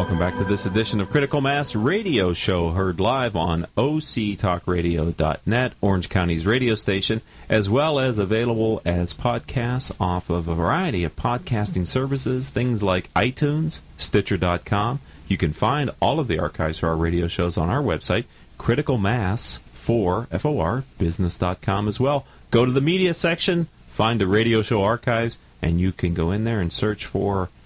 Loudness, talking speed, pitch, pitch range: -22 LUFS, 160 wpm, 100 Hz, 90-120 Hz